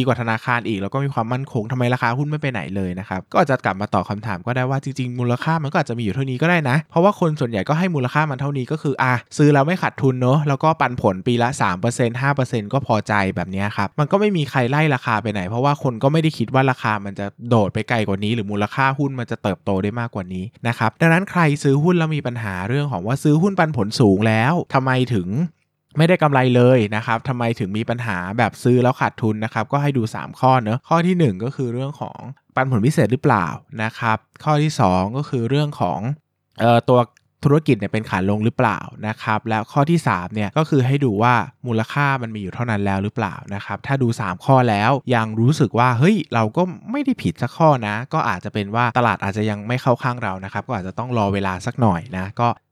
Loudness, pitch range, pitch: -19 LUFS, 110-140 Hz, 120 Hz